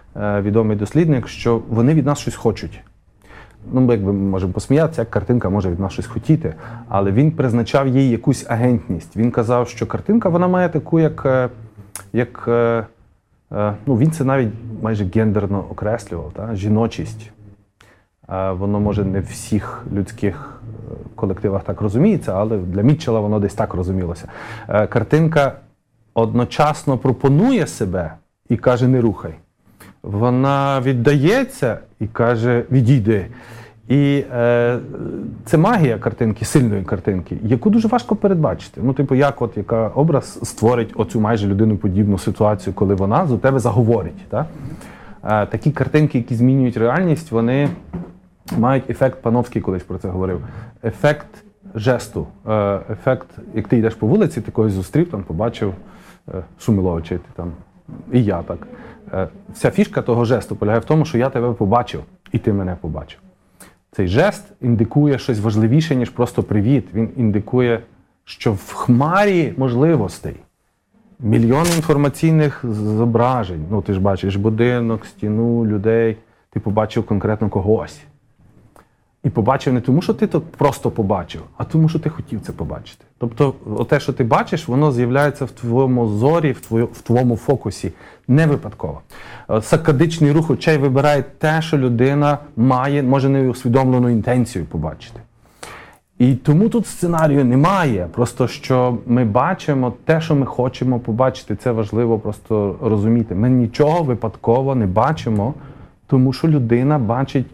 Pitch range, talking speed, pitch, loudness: 105-135 Hz, 140 wpm, 120 Hz, -18 LUFS